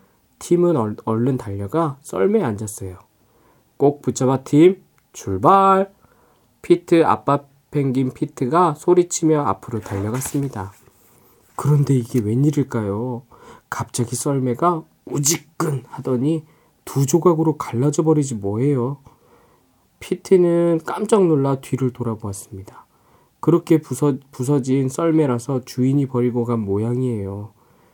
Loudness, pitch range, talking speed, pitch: -19 LUFS, 120-160 Hz, 260 characters per minute, 135 Hz